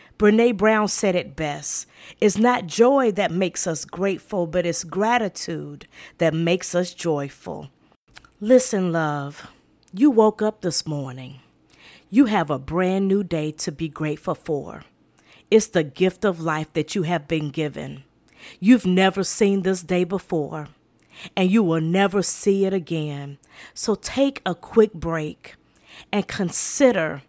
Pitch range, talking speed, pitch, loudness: 155-205 Hz, 145 wpm, 180 Hz, -21 LUFS